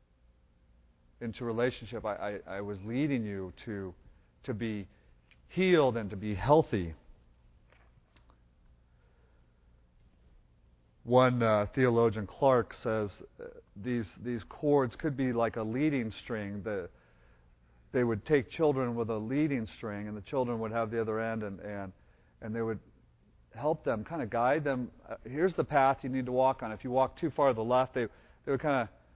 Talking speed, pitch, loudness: 165 wpm, 110 Hz, -32 LUFS